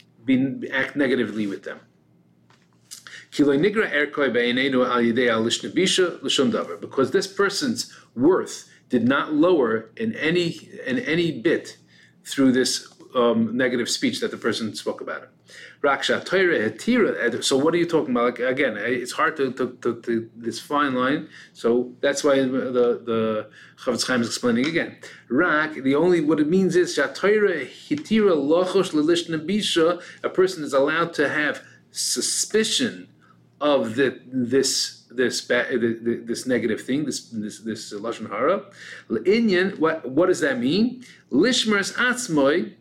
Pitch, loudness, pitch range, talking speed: 145 Hz, -22 LUFS, 120-200 Hz, 120 wpm